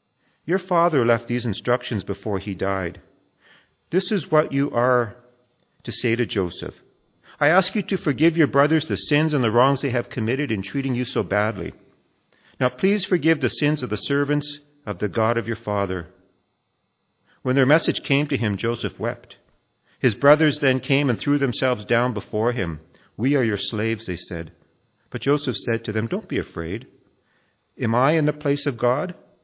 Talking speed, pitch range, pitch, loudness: 185 wpm, 110-145 Hz, 125 Hz, -22 LUFS